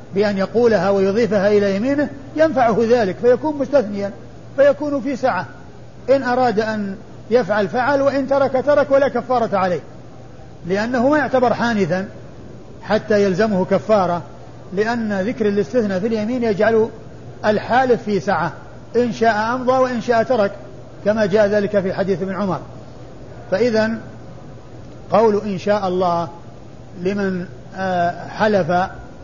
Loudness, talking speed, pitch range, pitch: -18 LUFS, 120 wpm, 190-240 Hz, 210 Hz